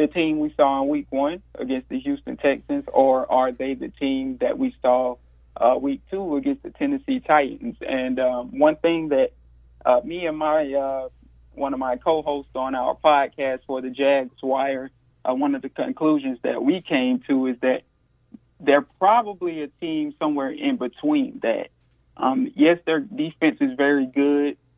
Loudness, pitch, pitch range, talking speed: -23 LUFS, 145 Hz, 130-180 Hz, 175 wpm